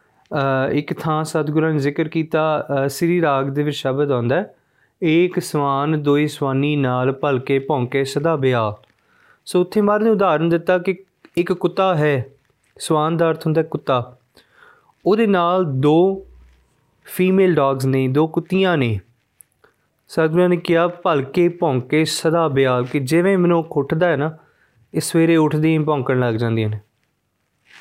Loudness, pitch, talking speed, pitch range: -18 LUFS, 155 Hz, 140 wpm, 135-175 Hz